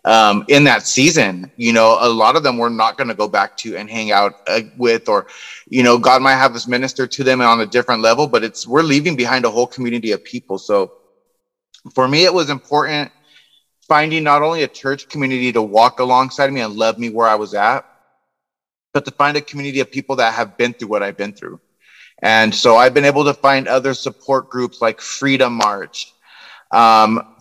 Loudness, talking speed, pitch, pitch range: -15 LUFS, 215 wpm, 125 Hz, 115-140 Hz